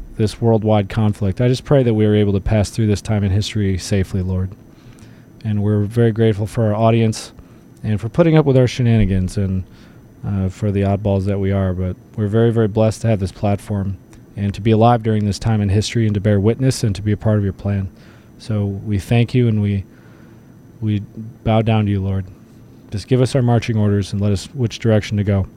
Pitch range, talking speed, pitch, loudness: 100-115 Hz, 225 wpm, 105 Hz, -18 LUFS